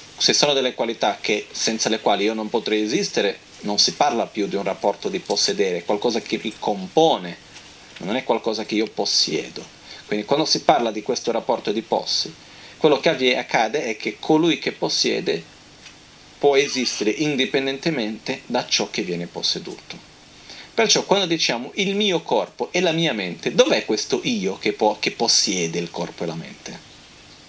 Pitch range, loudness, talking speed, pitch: 110-165 Hz, -21 LUFS, 170 wpm, 135 Hz